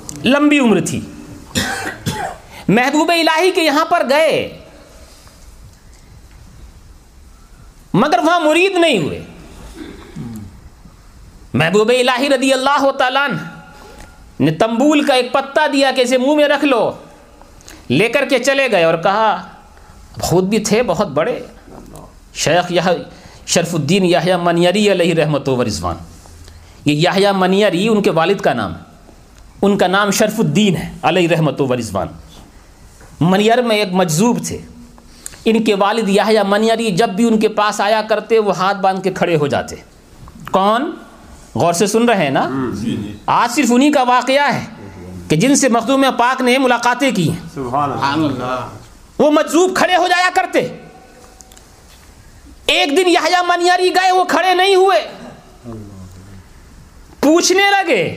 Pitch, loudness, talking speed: 210 Hz, -14 LUFS, 140 wpm